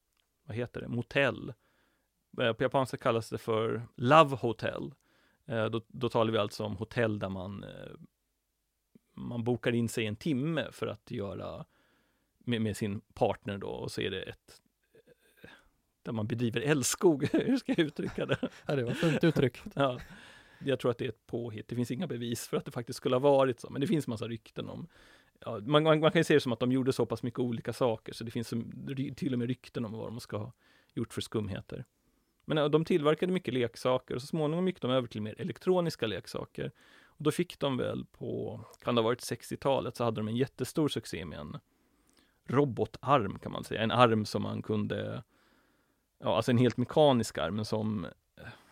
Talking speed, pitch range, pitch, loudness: 205 wpm, 110-140 Hz, 120 Hz, -32 LUFS